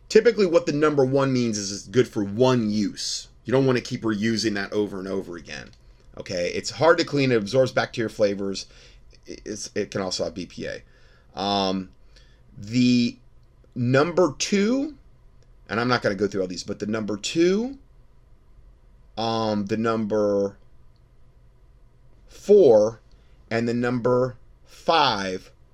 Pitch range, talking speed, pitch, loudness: 100-130 Hz, 145 wpm, 115 Hz, -23 LUFS